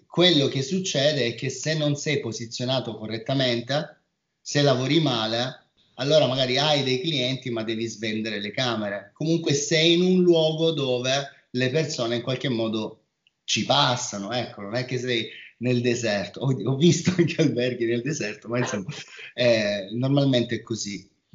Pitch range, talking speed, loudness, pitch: 115-150 Hz, 155 wpm, -24 LUFS, 130 Hz